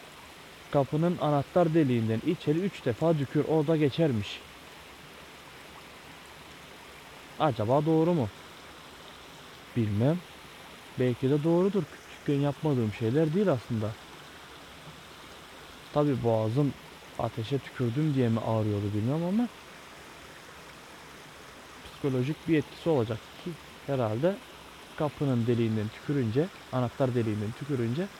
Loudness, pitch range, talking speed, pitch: -29 LUFS, 115-160 Hz, 90 wpm, 140 Hz